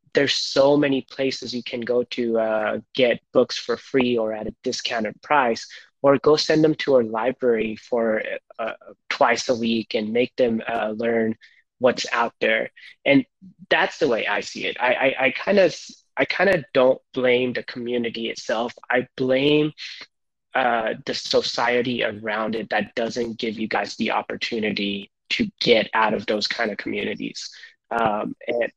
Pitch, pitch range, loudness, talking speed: 120 Hz, 110-135 Hz, -22 LUFS, 170 wpm